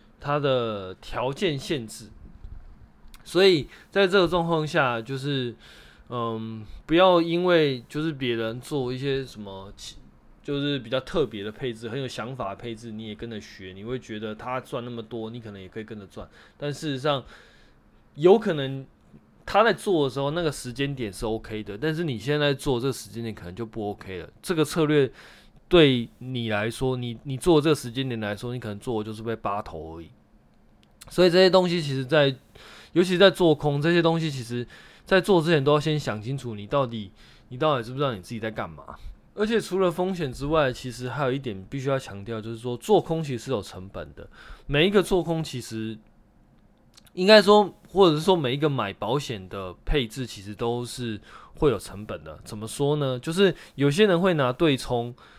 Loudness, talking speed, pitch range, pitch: -25 LUFS, 285 characters per minute, 110-155 Hz, 125 Hz